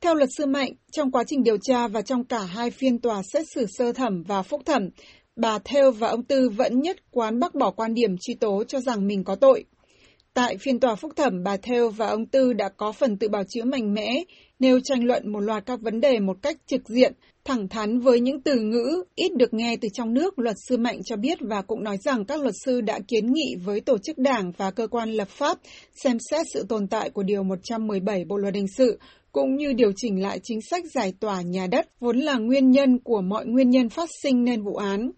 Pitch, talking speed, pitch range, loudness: 240 Hz, 245 wpm, 215-270 Hz, -24 LUFS